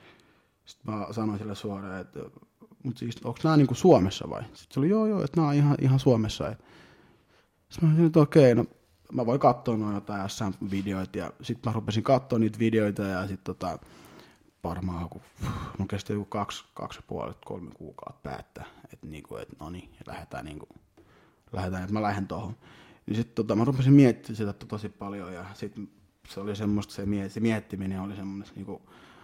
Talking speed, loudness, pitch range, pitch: 195 wpm, -27 LUFS, 100-120 Hz, 105 Hz